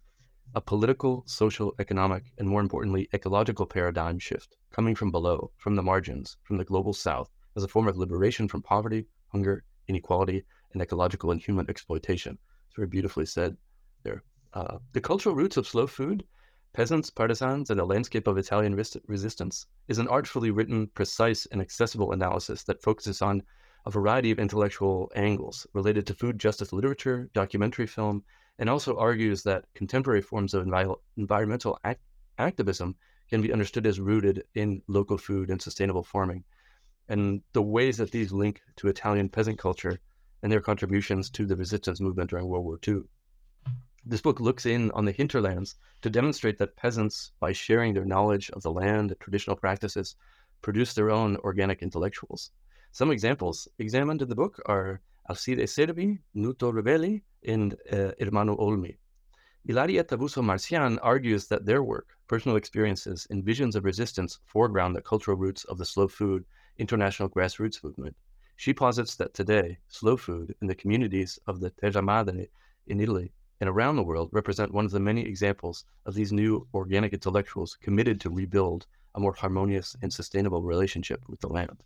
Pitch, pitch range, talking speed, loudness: 100 Hz, 95-110 Hz, 165 wpm, -28 LUFS